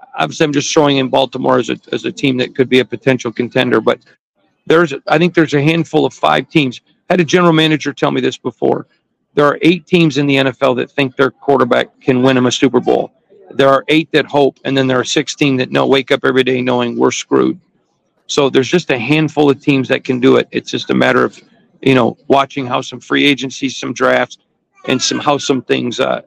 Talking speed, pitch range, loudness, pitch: 240 wpm, 130-155 Hz, -13 LUFS, 135 Hz